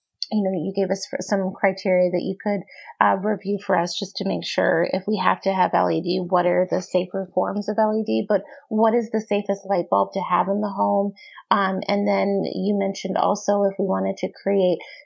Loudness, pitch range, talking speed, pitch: -22 LUFS, 180-205 Hz, 215 wpm, 195 Hz